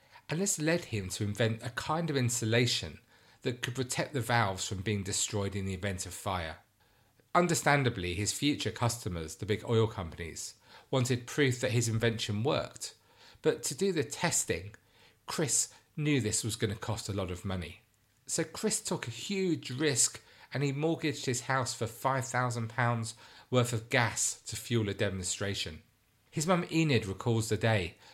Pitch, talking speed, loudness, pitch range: 115 Hz, 170 wpm, -32 LUFS, 105-135 Hz